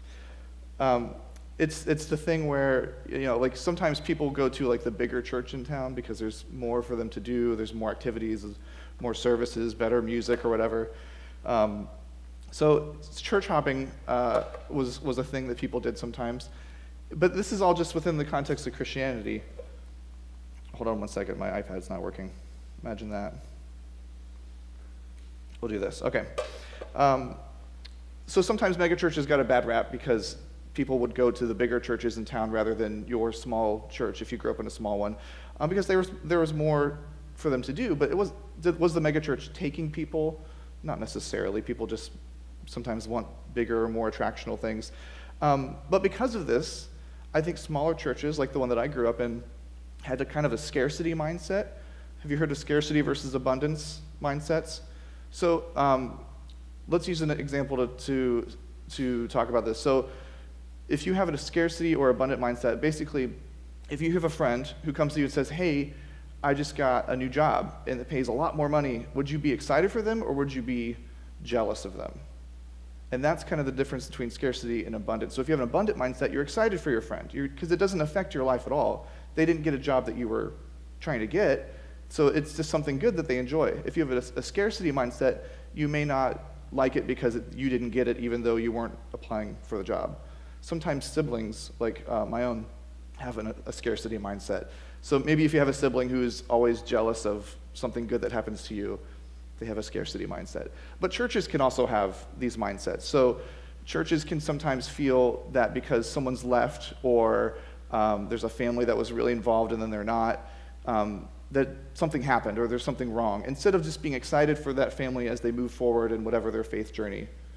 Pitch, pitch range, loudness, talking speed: 120 Hz, 95-145 Hz, -29 LUFS, 200 wpm